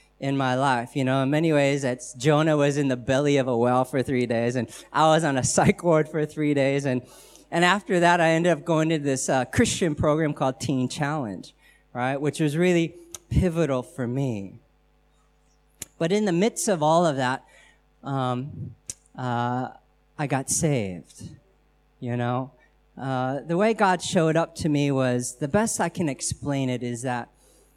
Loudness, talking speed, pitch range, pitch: -24 LUFS, 185 wpm, 125-160 Hz, 140 Hz